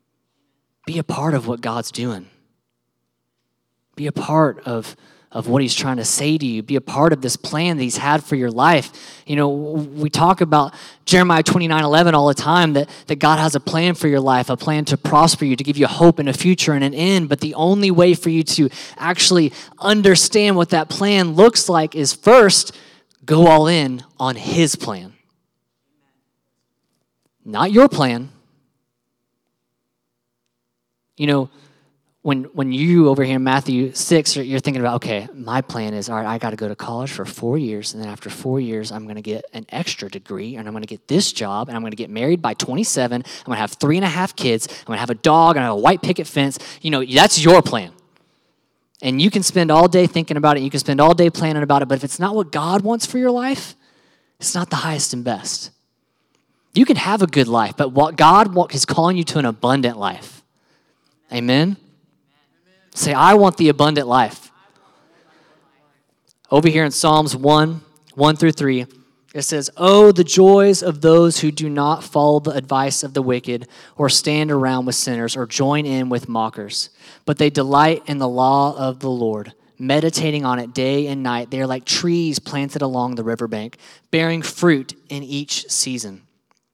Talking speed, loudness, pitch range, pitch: 200 wpm, -16 LUFS, 125-165 Hz, 145 Hz